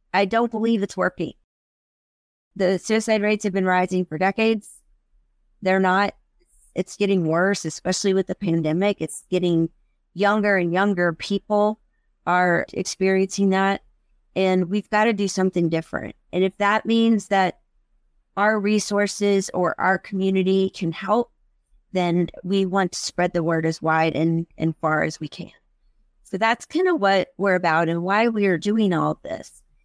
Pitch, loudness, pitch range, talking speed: 190 Hz, -22 LUFS, 175-205 Hz, 160 wpm